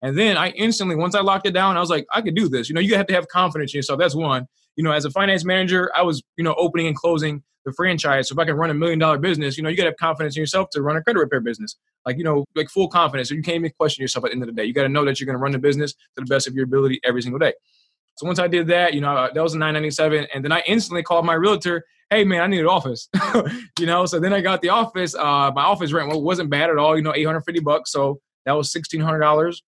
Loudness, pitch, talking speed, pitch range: -20 LUFS, 160 Hz, 310 wpm, 145-180 Hz